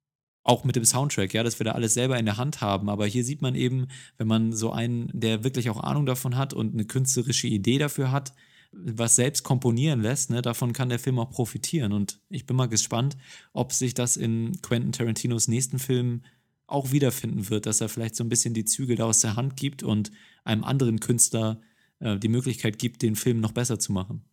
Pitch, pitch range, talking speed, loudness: 120 Hz, 110-130 Hz, 220 wpm, -25 LUFS